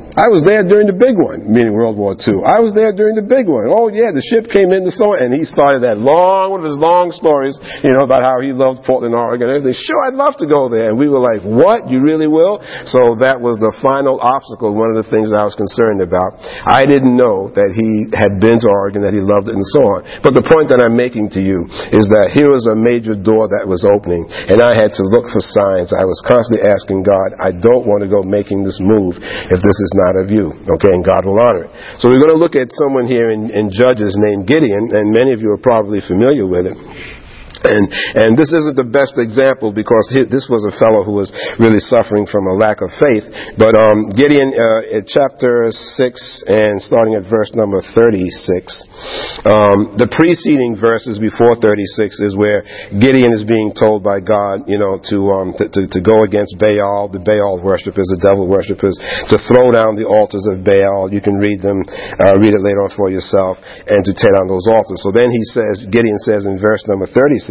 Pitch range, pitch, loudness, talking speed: 100-130 Hz, 110 Hz, -12 LUFS, 235 wpm